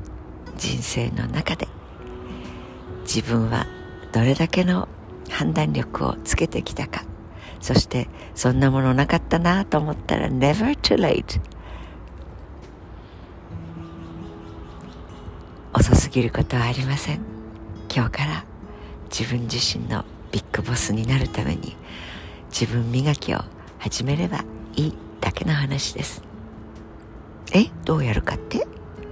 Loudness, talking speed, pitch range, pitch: -23 LUFS, 225 characters per minute, 85-125 Hz, 110 Hz